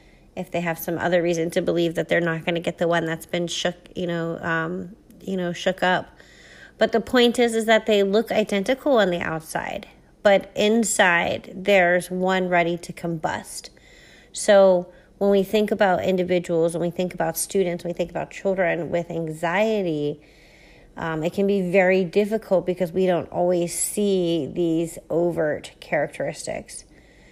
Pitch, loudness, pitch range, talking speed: 180 Hz, -22 LUFS, 170-200 Hz, 170 wpm